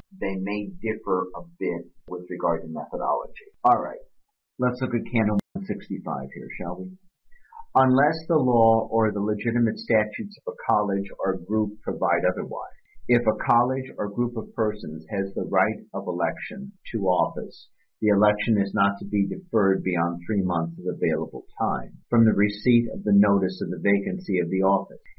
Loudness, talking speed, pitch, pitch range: -25 LUFS, 170 wpm, 105 Hz, 100-120 Hz